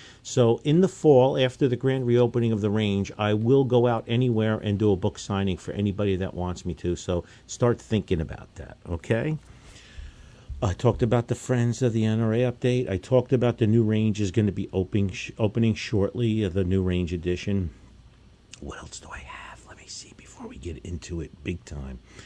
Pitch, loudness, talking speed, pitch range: 110 Hz, -25 LUFS, 200 wpm, 95-120 Hz